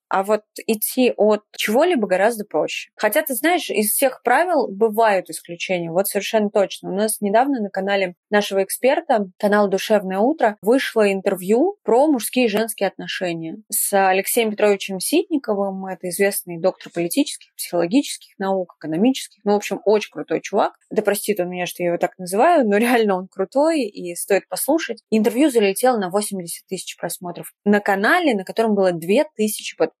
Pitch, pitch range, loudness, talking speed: 205 Hz, 190-235 Hz, -20 LUFS, 160 wpm